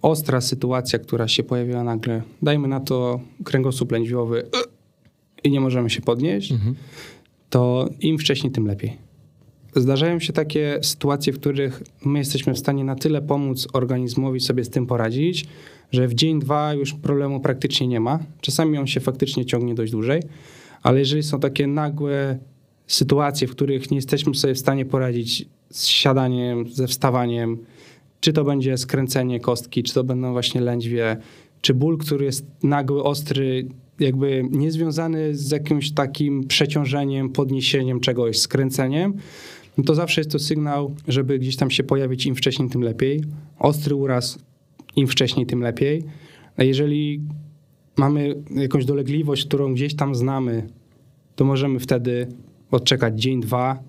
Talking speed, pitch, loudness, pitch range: 150 wpm, 135 Hz, -21 LUFS, 125-145 Hz